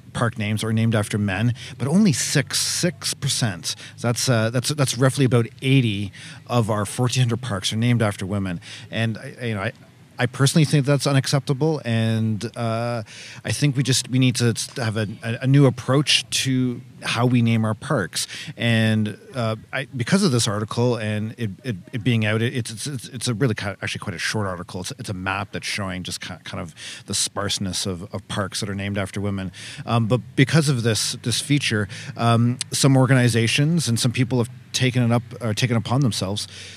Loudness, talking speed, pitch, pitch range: -22 LUFS, 200 wpm, 120 Hz, 110-130 Hz